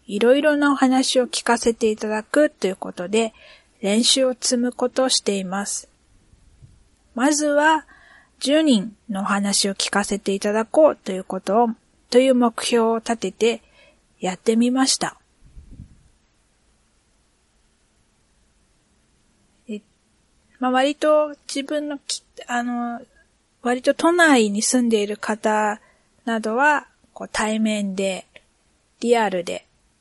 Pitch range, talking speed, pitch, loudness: 210-265 Hz, 215 characters per minute, 235 Hz, -20 LUFS